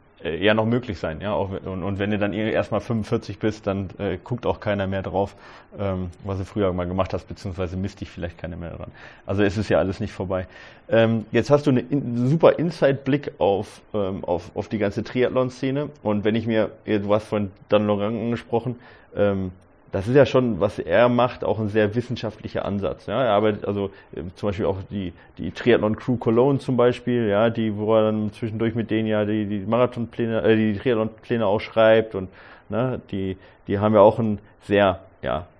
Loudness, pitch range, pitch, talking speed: -23 LUFS, 100-115 Hz, 105 Hz, 205 wpm